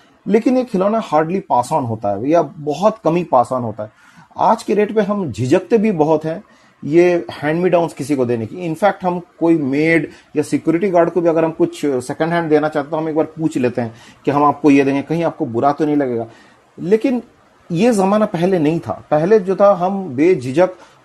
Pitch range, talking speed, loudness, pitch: 145-190 Hz, 215 wpm, -16 LUFS, 160 Hz